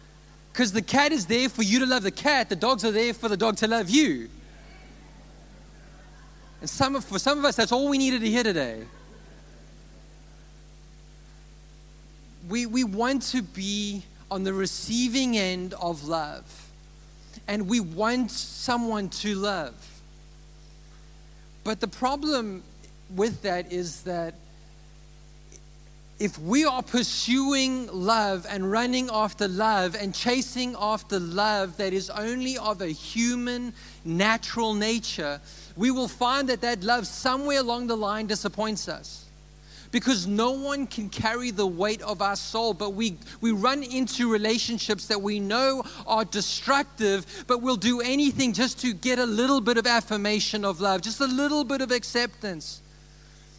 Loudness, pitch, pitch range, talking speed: -26 LUFS, 220 Hz, 190-245 Hz, 150 wpm